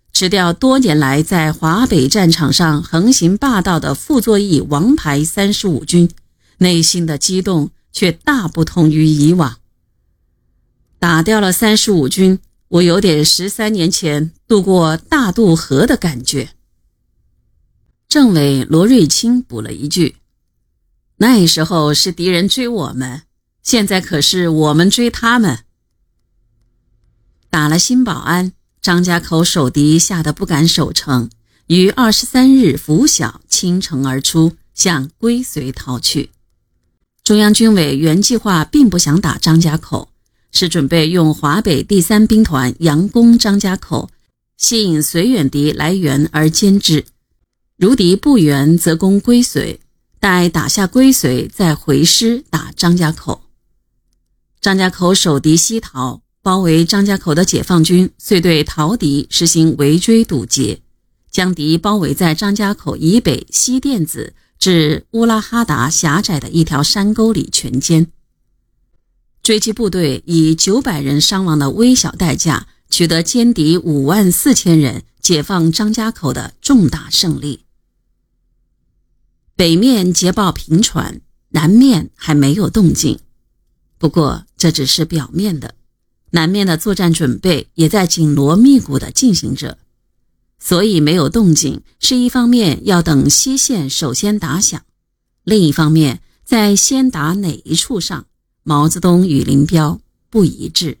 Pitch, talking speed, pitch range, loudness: 170 Hz, 205 characters per minute, 150-205 Hz, -13 LUFS